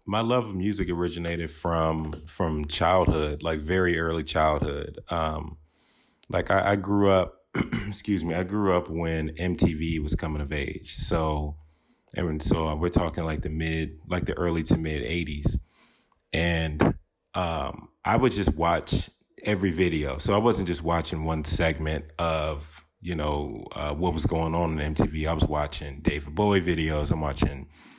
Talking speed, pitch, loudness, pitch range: 165 wpm, 80 Hz, -27 LUFS, 75-90 Hz